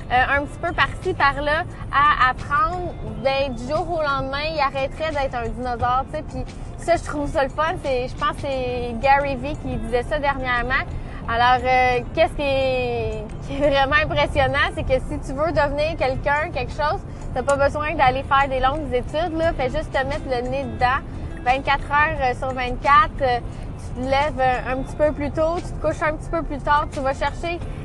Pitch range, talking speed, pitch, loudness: 260-300 Hz, 205 wpm, 280 Hz, -21 LUFS